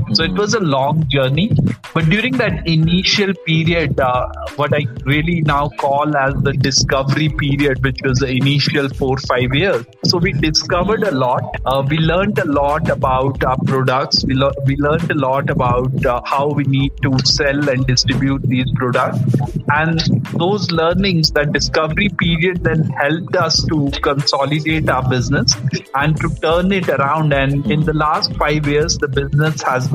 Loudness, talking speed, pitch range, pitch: -16 LUFS, 170 wpm, 135-160 Hz, 145 Hz